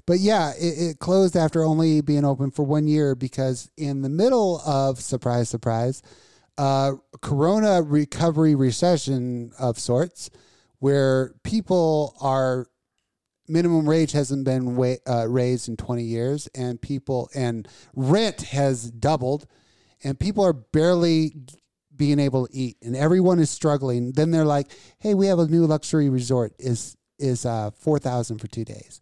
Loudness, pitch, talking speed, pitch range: -22 LUFS, 140 Hz, 150 wpm, 125-155 Hz